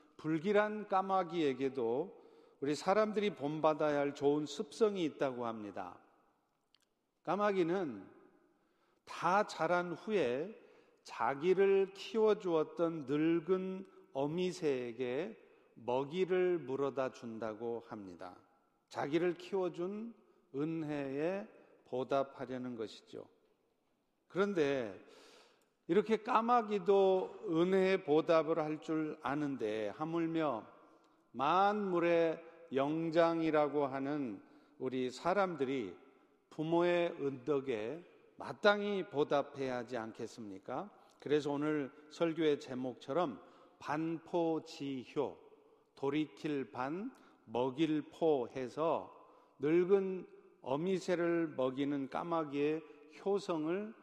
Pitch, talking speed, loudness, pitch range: 160 Hz, 205 characters per minute, -36 LUFS, 140-190 Hz